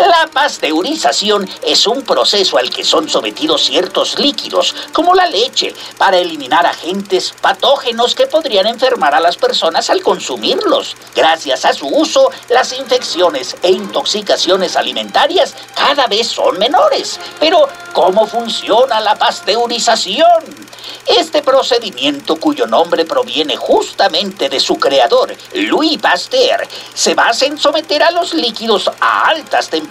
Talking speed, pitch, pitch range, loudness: 130 wpm, 275 Hz, 230-325 Hz, -12 LUFS